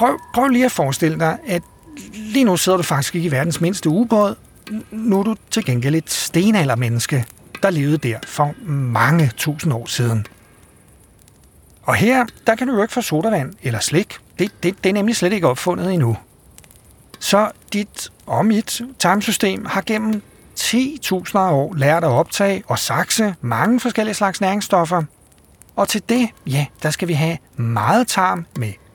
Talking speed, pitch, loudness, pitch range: 170 wpm, 180 Hz, -18 LUFS, 145-215 Hz